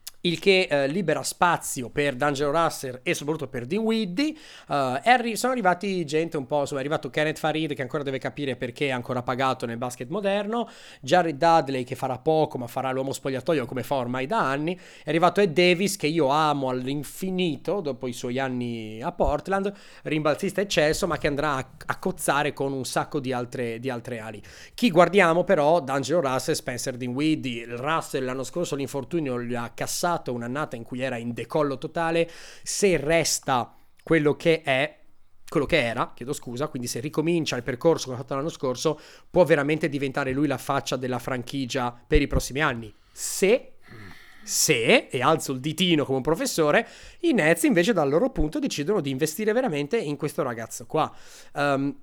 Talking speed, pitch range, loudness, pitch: 180 wpm, 130-165 Hz, -25 LUFS, 145 Hz